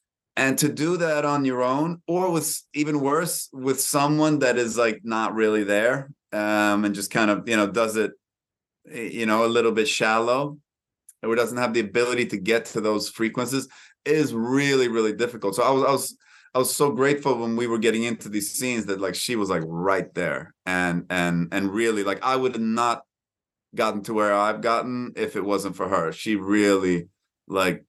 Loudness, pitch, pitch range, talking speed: -23 LUFS, 115 Hz, 105-135 Hz, 200 wpm